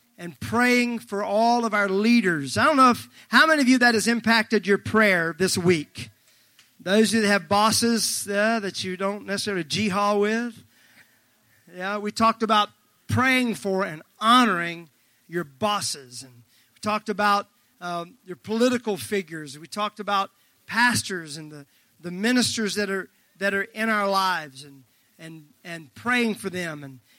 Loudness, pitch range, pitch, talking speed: -22 LUFS, 170-220 Hz, 200 Hz, 165 wpm